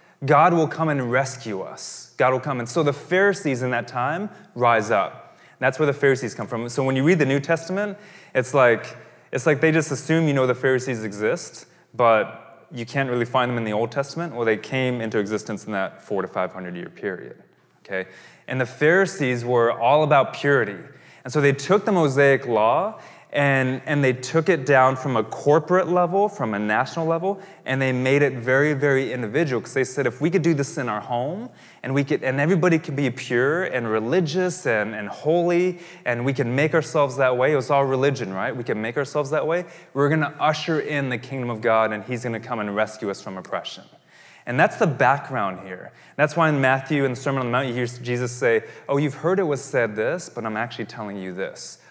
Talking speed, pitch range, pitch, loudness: 225 wpm, 120-155 Hz, 135 Hz, -22 LUFS